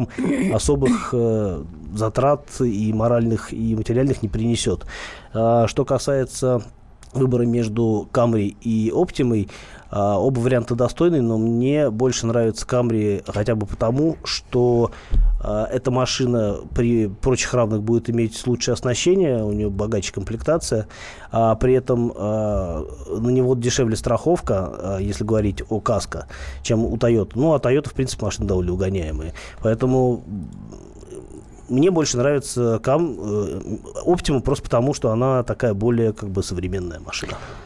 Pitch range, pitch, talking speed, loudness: 105-125 Hz, 115 Hz, 135 wpm, -21 LUFS